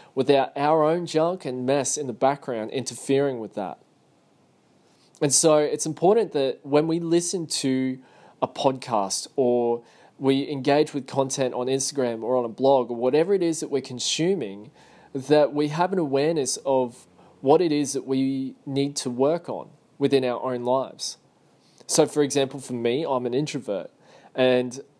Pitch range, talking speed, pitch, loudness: 130-150 Hz, 165 wpm, 135 Hz, -24 LUFS